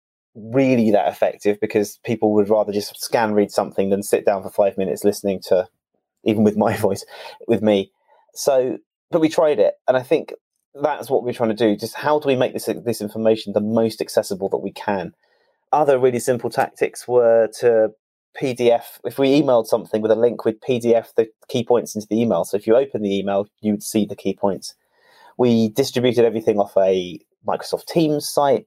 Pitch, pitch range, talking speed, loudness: 110 Hz, 105-125 Hz, 195 wpm, -20 LUFS